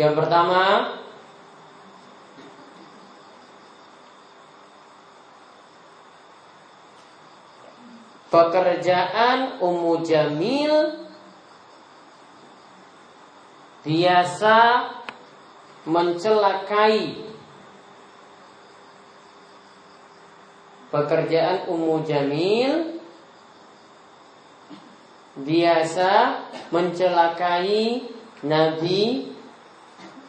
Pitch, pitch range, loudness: 180 Hz, 165-230 Hz, -21 LUFS